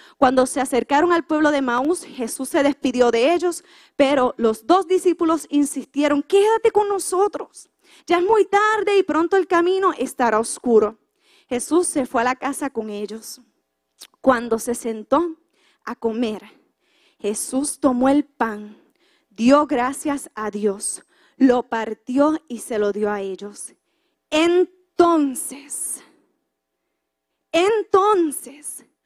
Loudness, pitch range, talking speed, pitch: -20 LUFS, 240-345 Hz, 125 wpm, 285 Hz